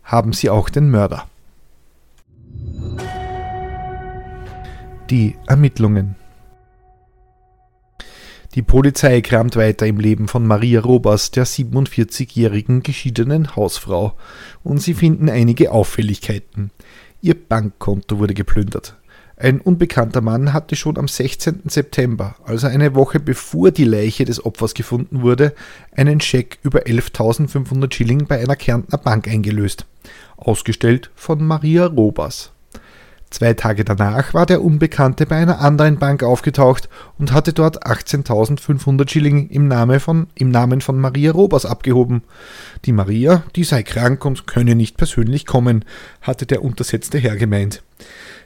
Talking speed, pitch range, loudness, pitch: 125 wpm, 110-140 Hz, -16 LUFS, 125 Hz